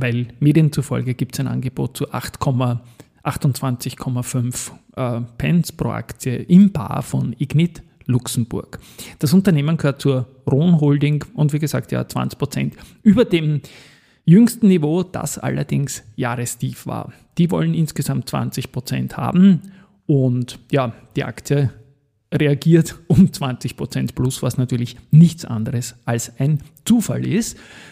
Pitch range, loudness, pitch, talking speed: 125-155 Hz, -19 LUFS, 135 Hz, 125 wpm